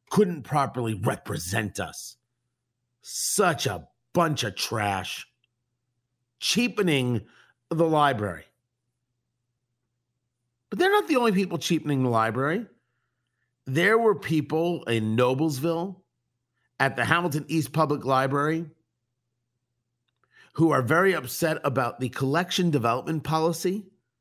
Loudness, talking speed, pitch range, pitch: -25 LUFS, 100 wpm, 120-165 Hz, 130 Hz